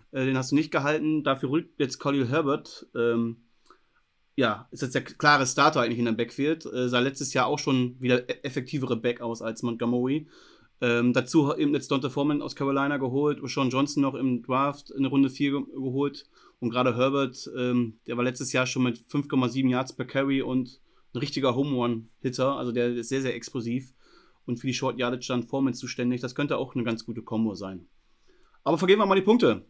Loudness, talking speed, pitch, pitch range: -27 LUFS, 200 wpm, 130 Hz, 120-140 Hz